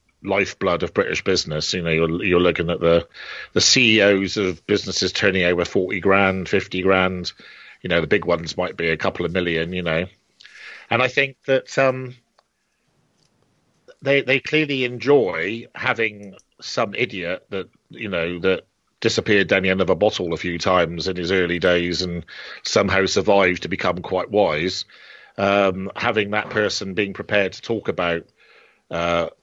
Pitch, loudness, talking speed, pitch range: 95 Hz, -20 LUFS, 165 wpm, 90-105 Hz